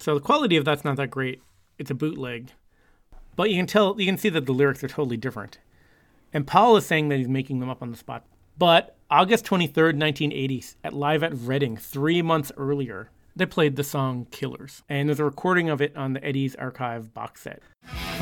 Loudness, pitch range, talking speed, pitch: -24 LUFS, 130-160 Hz, 215 wpm, 140 Hz